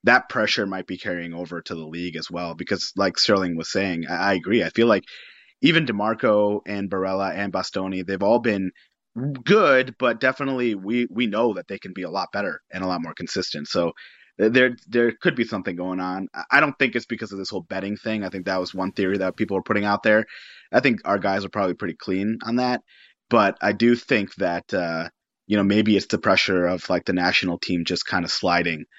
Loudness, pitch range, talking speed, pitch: -22 LUFS, 90-115 Hz, 225 wpm, 100 Hz